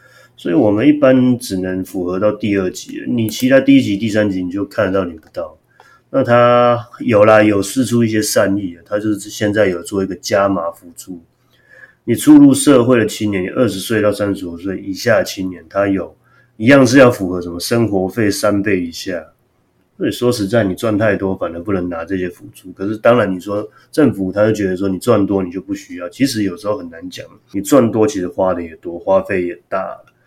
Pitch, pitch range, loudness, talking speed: 100 Hz, 95-115 Hz, -15 LUFS, 305 characters per minute